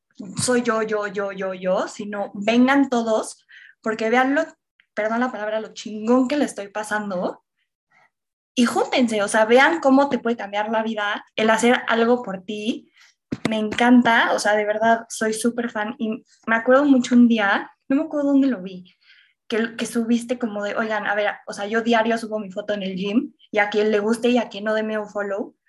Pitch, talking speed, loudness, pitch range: 225 Hz, 205 wpm, -21 LUFS, 210-245 Hz